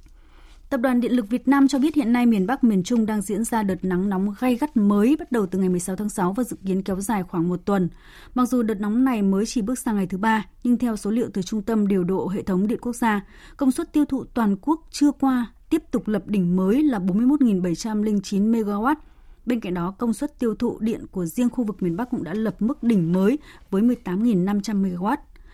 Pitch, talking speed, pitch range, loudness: 220 Hz, 240 wpm, 195-250 Hz, -23 LUFS